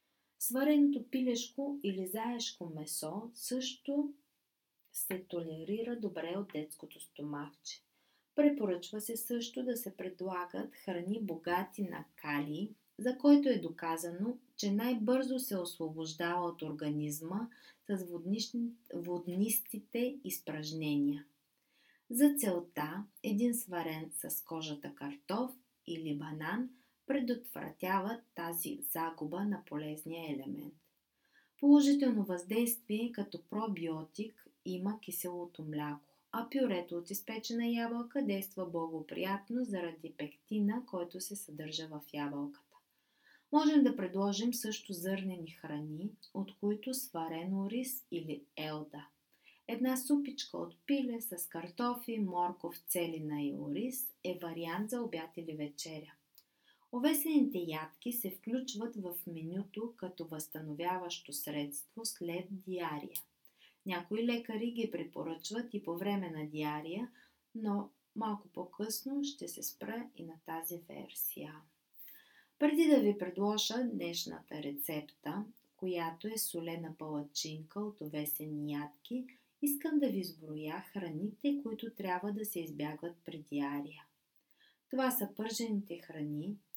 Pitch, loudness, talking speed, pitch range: 190 Hz, -37 LUFS, 110 wpm, 165-235 Hz